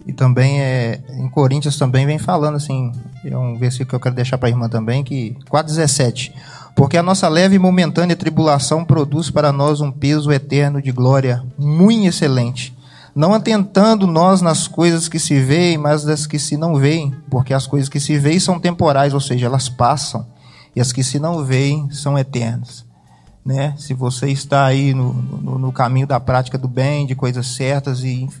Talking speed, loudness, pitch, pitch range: 190 wpm, -16 LUFS, 140 Hz, 130-150 Hz